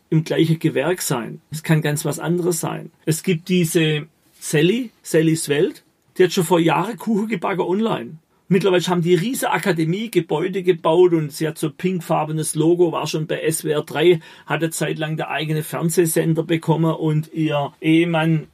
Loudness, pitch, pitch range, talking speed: -20 LUFS, 165 Hz, 155-180 Hz, 165 wpm